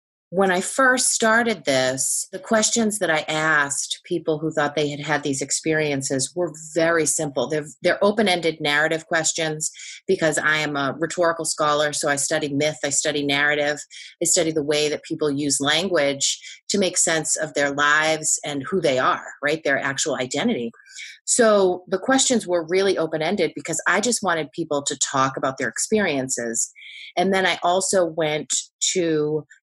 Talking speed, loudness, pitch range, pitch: 170 wpm, -21 LUFS, 145-180 Hz, 155 Hz